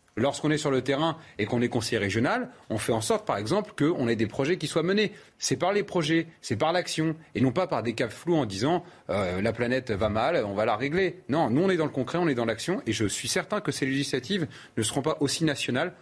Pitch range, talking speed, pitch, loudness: 120-165 Hz, 265 wpm, 140 Hz, -27 LUFS